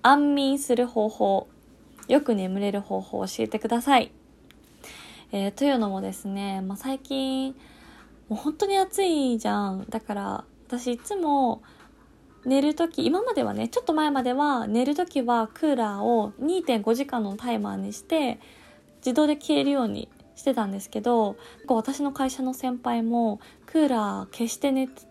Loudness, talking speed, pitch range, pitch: -26 LUFS, 290 characters per minute, 220-280 Hz, 250 Hz